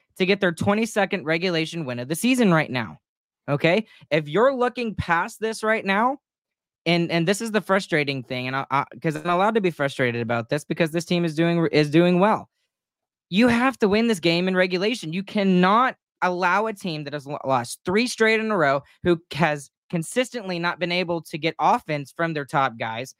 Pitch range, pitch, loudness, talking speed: 150-205 Hz, 175 Hz, -22 LUFS, 205 wpm